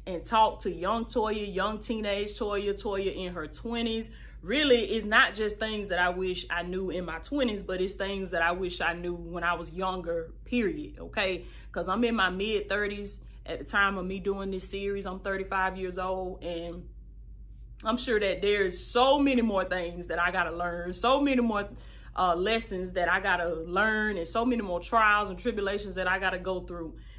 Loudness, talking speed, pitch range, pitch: -29 LUFS, 200 wpm, 180-215 Hz, 195 Hz